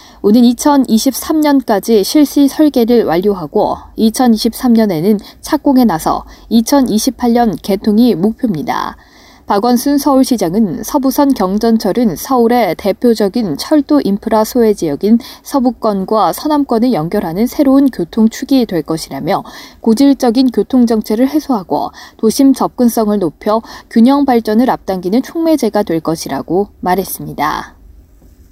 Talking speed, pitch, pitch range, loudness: 275 characters per minute, 230 Hz, 205-265 Hz, -12 LUFS